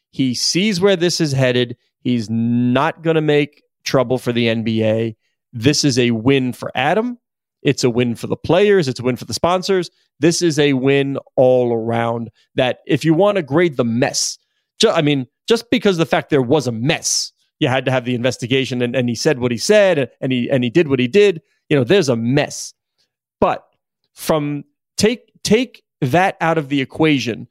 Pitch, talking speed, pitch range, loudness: 140 Hz, 205 wpm, 125-170 Hz, -17 LUFS